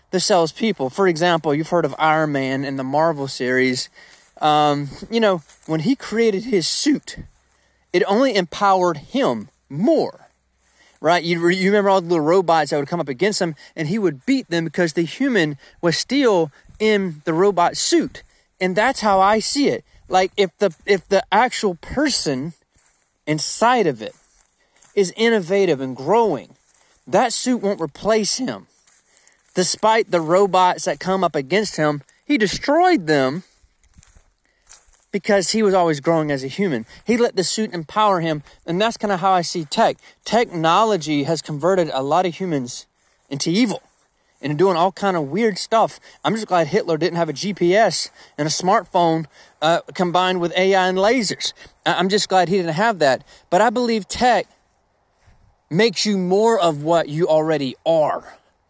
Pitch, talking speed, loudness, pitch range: 180 Hz, 170 wpm, -19 LUFS, 155-205 Hz